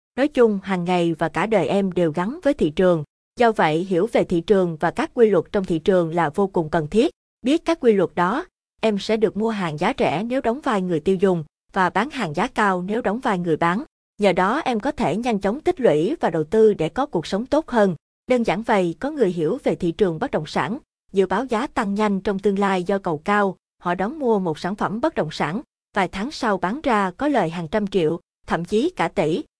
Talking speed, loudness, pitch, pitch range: 250 wpm, -21 LUFS, 200 Hz, 175-225 Hz